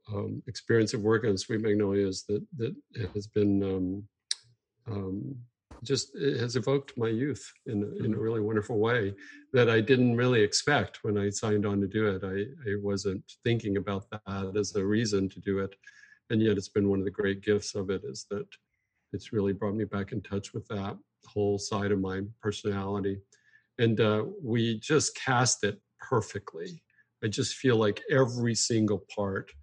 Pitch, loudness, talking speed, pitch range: 105 Hz, -30 LUFS, 180 wpm, 100-115 Hz